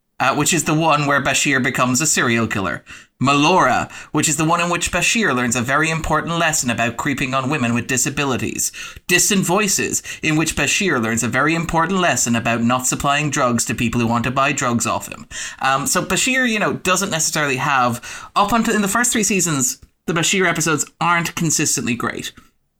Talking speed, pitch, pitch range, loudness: 195 wpm, 150 Hz, 125-170 Hz, -17 LUFS